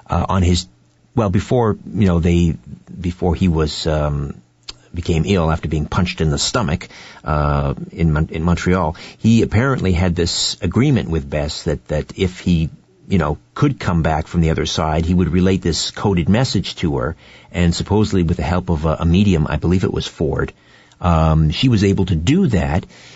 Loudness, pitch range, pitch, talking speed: -18 LUFS, 80-95 Hz, 85 Hz, 190 wpm